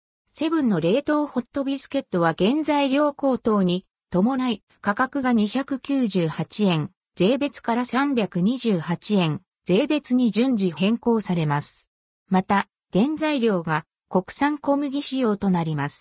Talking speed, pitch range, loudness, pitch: 225 characters per minute, 180-275 Hz, -23 LUFS, 225 Hz